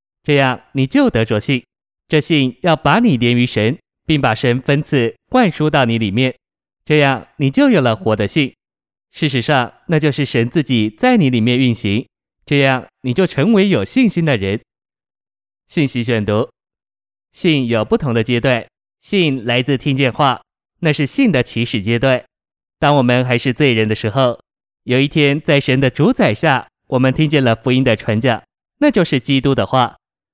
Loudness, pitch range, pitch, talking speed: -15 LUFS, 120-150 Hz, 130 Hz, 240 characters per minute